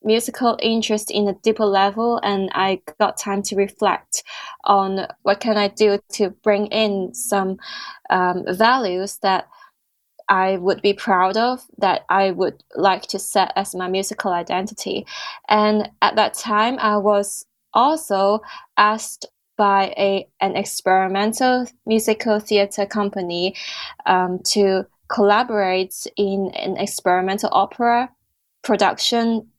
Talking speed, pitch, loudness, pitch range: 125 wpm, 200 Hz, -19 LUFS, 195-220 Hz